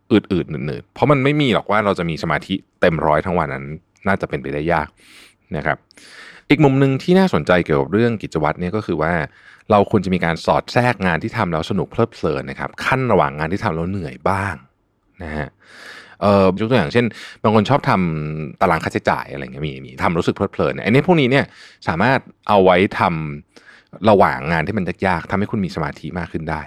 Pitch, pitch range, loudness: 95 Hz, 80-110 Hz, -18 LUFS